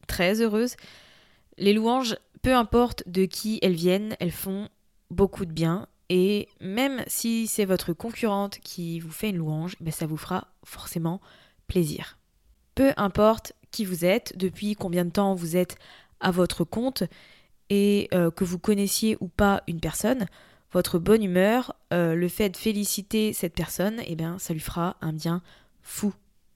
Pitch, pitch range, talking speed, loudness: 190 Hz, 175-215 Hz, 165 wpm, -26 LUFS